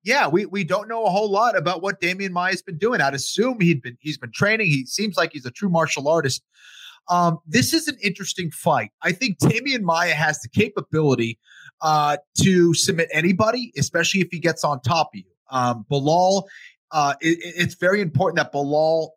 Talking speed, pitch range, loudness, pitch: 200 wpm, 150-195 Hz, -21 LUFS, 170 Hz